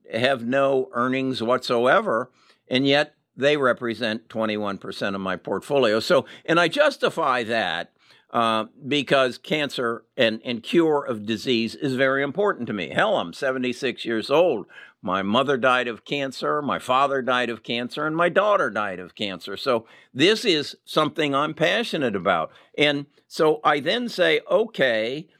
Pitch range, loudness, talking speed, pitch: 120-150 Hz, -23 LUFS, 150 wpm, 130 Hz